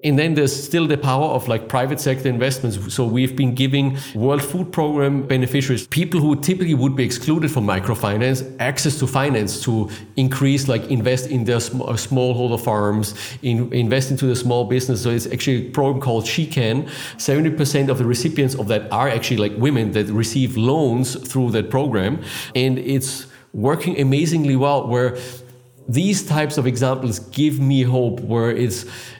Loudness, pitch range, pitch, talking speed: -19 LUFS, 120-140 Hz, 130 Hz, 175 wpm